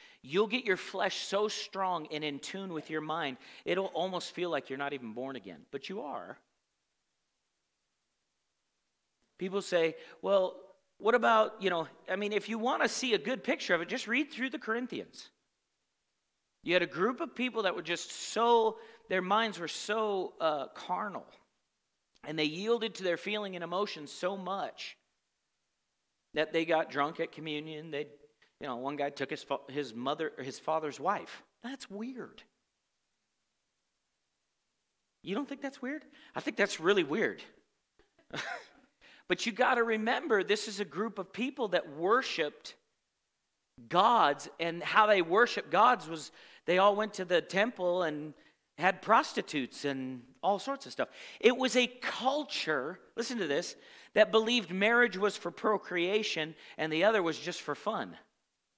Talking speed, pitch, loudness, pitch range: 165 wpm, 195 Hz, -32 LUFS, 160-230 Hz